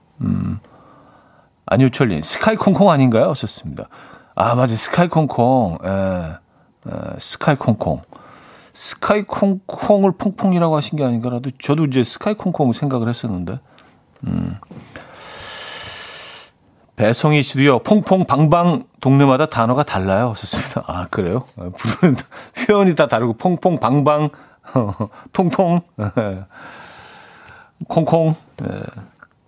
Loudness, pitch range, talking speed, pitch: -17 LUFS, 120-175 Hz, 235 characters per minute, 140 Hz